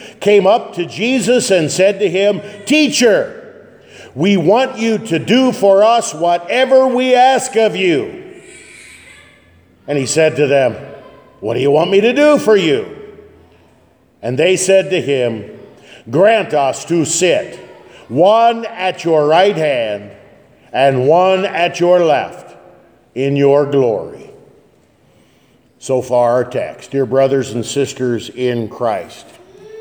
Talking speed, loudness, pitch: 135 wpm, -13 LUFS, 185 Hz